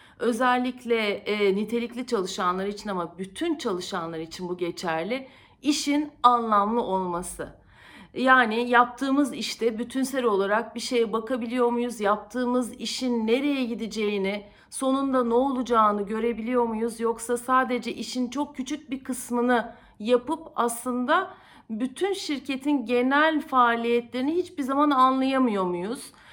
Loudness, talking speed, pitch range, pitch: -25 LUFS, 110 wpm, 220-260 Hz, 240 Hz